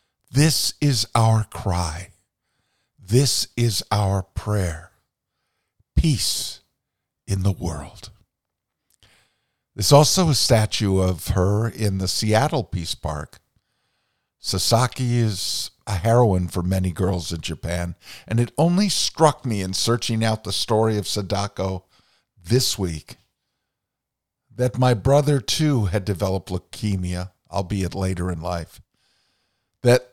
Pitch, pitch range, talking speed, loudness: 105 Hz, 95-120 Hz, 115 wpm, -21 LUFS